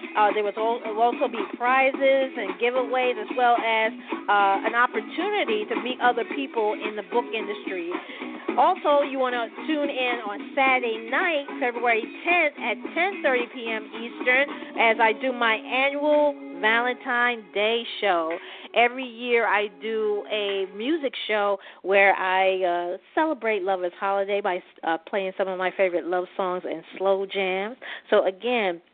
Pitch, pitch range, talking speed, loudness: 235 Hz, 200-275 Hz, 150 wpm, -24 LUFS